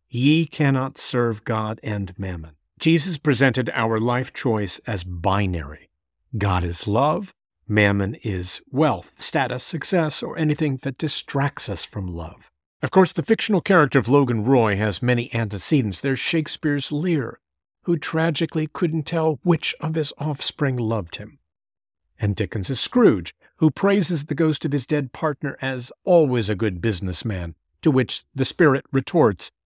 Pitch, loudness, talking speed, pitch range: 130 Hz, -22 LUFS, 150 wpm, 105-155 Hz